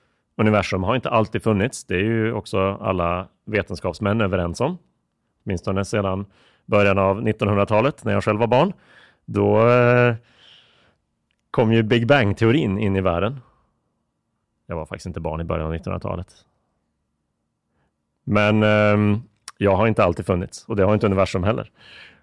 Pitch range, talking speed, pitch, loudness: 95-110 Hz, 140 wpm, 105 Hz, -20 LUFS